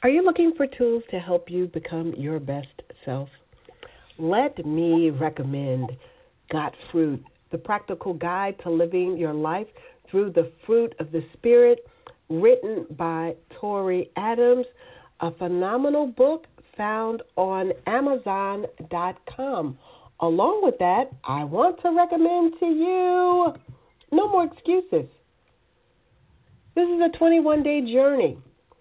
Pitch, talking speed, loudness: 200 Hz, 120 wpm, -23 LUFS